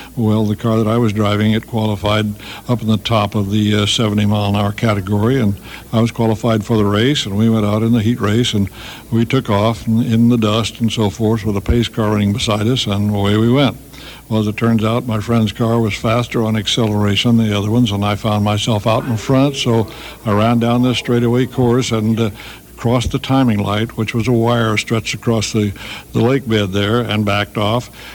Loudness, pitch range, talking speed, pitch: -16 LUFS, 105-120 Hz, 230 wpm, 110 Hz